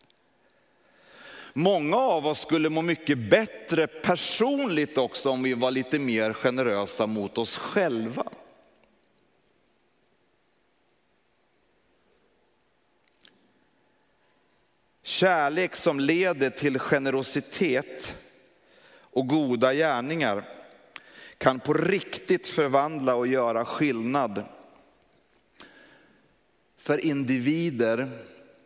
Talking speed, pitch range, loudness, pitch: 75 wpm, 130-160 Hz, -26 LUFS, 140 Hz